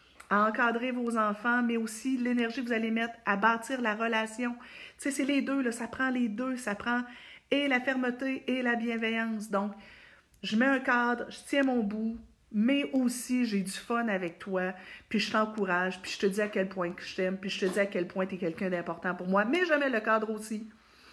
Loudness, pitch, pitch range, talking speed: -30 LUFS, 225 Hz, 200-245 Hz, 225 wpm